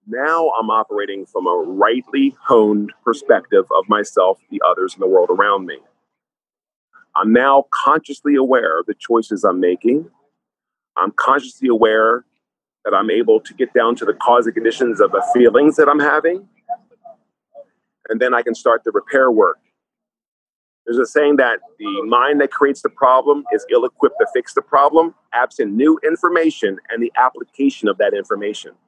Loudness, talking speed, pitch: -16 LUFS, 165 wpm, 200 Hz